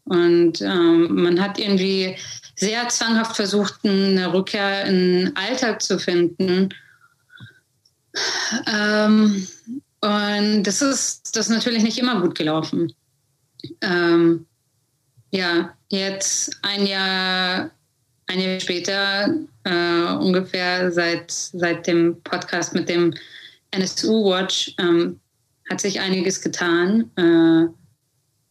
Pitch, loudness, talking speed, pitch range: 185 Hz, -20 LUFS, 105 wpm, 170-200 Hz